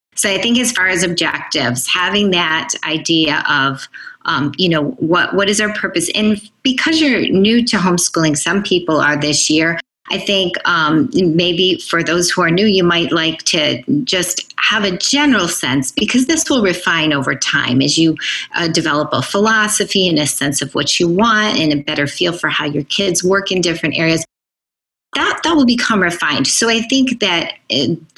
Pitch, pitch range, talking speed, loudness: 180 Hz, 160-210 Hz, 190 wpm, -14 LUFS